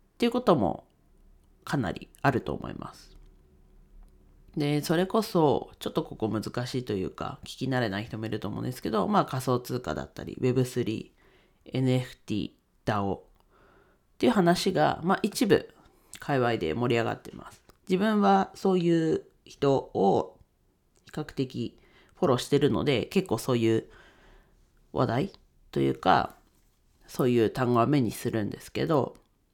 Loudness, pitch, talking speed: -28 LUFS, 125 Hz, 290 characters per minute